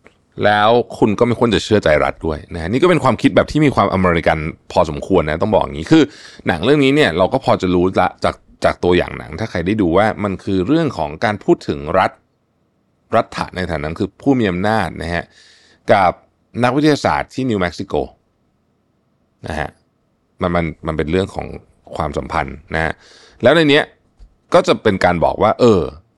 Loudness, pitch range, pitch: -16 LUFS, 85-120 Hz, 95 Hz